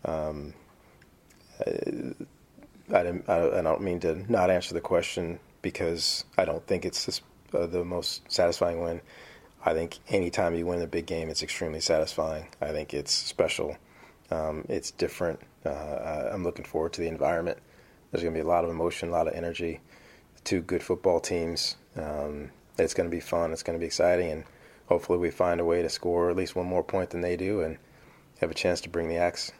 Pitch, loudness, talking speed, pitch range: 85 Hz, -29 LUFS, 195 wpm, 80-90 Hz